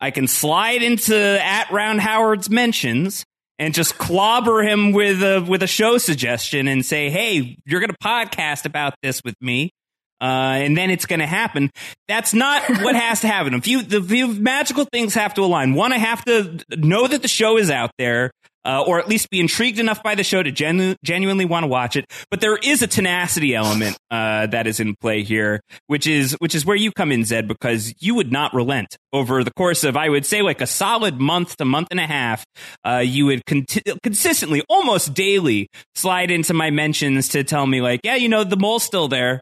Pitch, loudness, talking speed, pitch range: 170 Hz, -18 LUFS, 215 wpm, 135-215 Hz